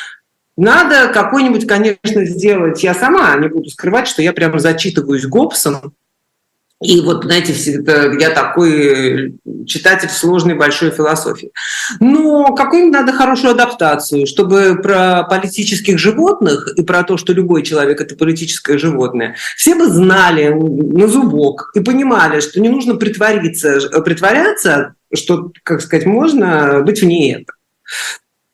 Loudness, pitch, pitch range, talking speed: -11 LUFS, 175 Hz, 155-210 Hz, 130 wpm